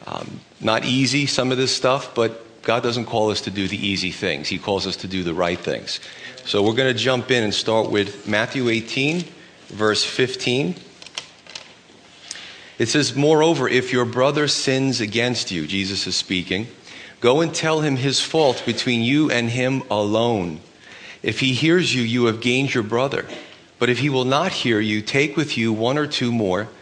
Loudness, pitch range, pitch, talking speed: -20 LUFS, 105-135 Hz, 120 Hz, 190 wpm